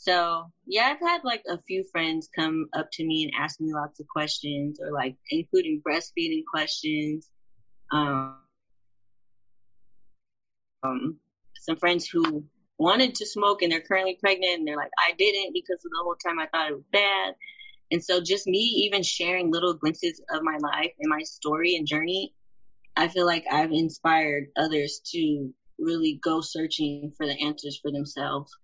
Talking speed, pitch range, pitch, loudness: 170 wpm, 145-185 Hz, 160 Hz, -26 LUFS